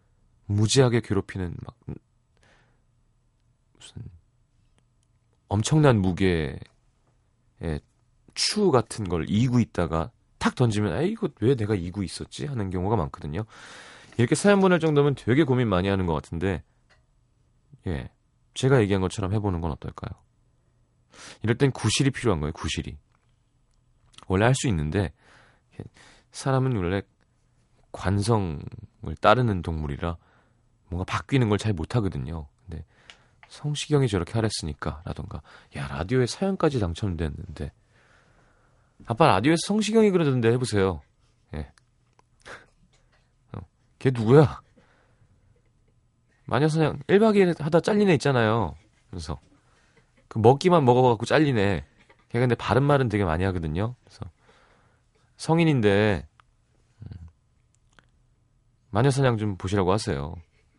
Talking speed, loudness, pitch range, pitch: 255 characters per minute, -24 LUFS, 95-125 Hz, 115 Hz